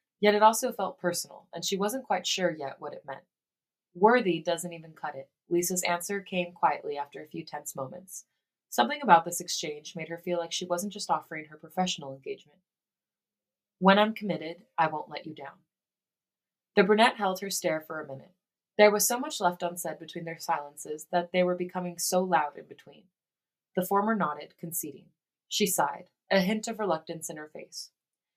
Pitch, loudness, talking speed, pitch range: 175 Hz, -28 LUFS, 190 wpm, 165-195 Hz